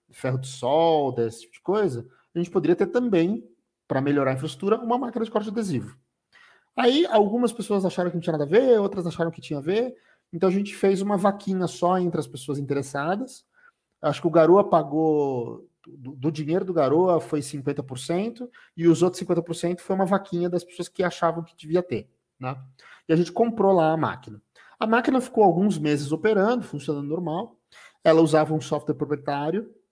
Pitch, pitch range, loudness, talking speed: 170 Hz, 150-200 Hz, -24 LUFS, 195 wpm